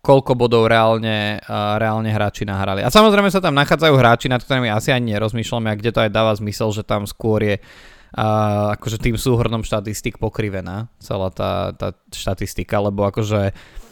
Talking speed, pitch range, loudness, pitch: 175 wpm, 105-120 Hz, -18 LUFS, 110 Hz